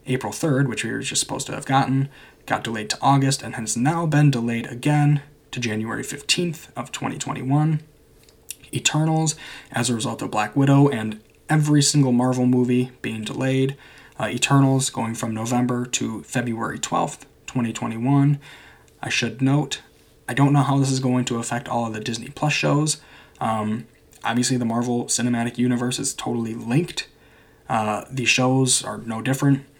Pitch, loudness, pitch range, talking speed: 130 Hz, -22 LUFS, 120-140 Hz, 165 wpm